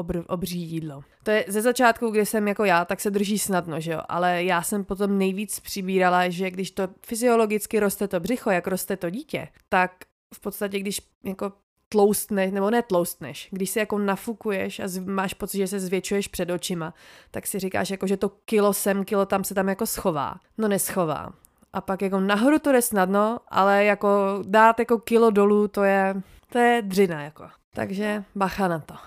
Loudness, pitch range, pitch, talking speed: -24 LUFS, 185-210 Hz, 200 Hz, 190 wpm